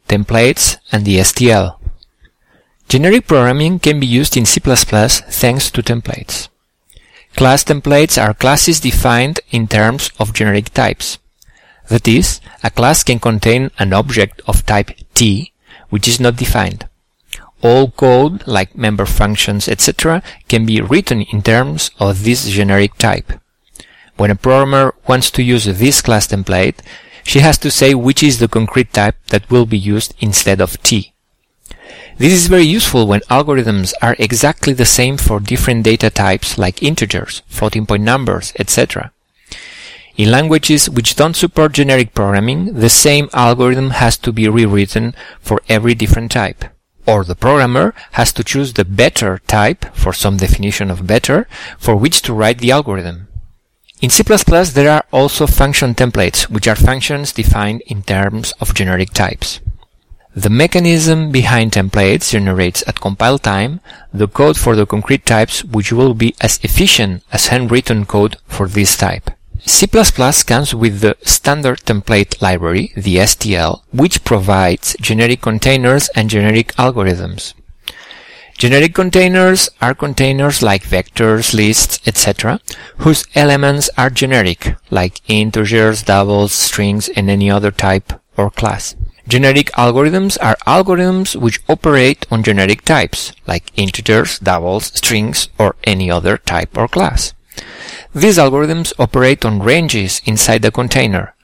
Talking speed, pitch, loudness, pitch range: 145 wpm, 115 Hz, -12 LUFS, 100-130 Hz